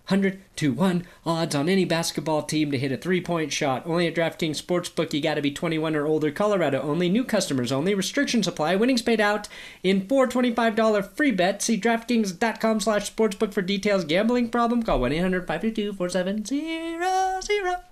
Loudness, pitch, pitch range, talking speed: -24 LUFS, 195 Hz, 165-225 Hz, 165 wpm